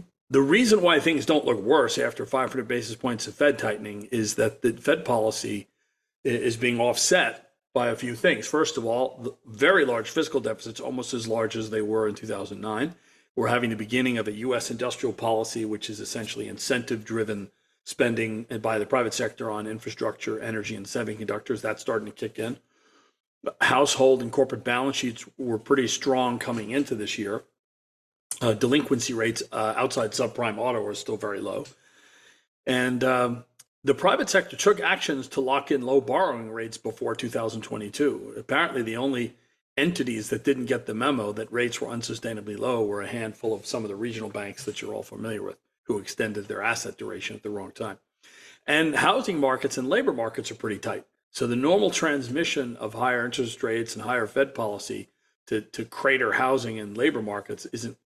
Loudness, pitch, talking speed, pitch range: -26 LUFS, 120 Hz, 180 wpm, 110-130 Hz